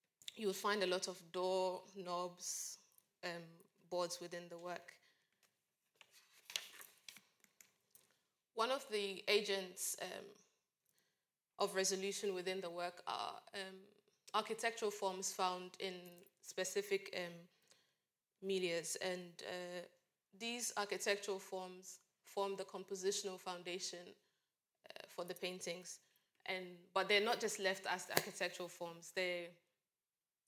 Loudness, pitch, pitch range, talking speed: -42 LUFS, 185 Hz, 180-200 Hz, 110 wpm